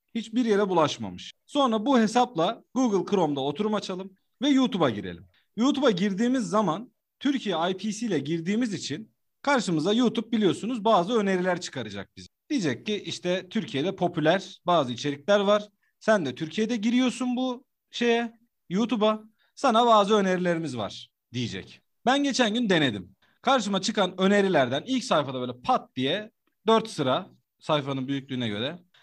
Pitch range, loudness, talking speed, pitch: 145-230 Hz, -26 LUFS, 135 wpm, 200 Hz